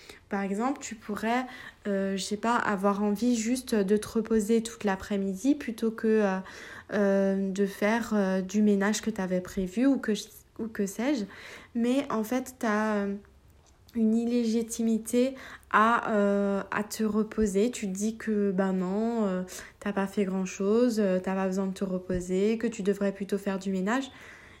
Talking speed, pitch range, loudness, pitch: 175 wpm, 195-230 Hz, -28 LUFS, 210 Hz